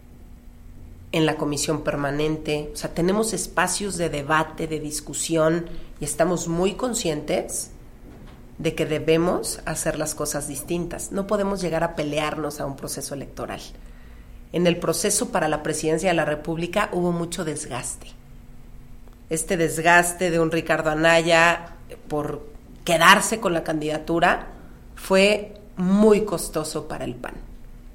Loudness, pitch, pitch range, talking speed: -23 LUFS, 160 Hz, 150-175 Hz, 130 wpm